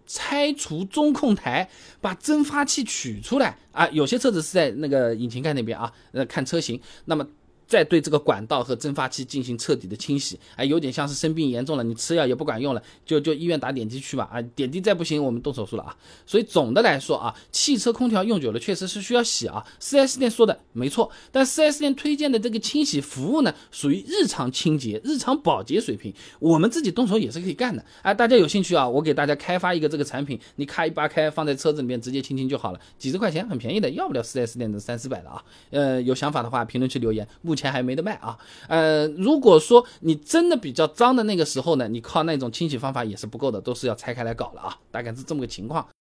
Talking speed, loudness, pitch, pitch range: 360 characters per minute, -23 LUFS, 150 Hz, 125-195 Hz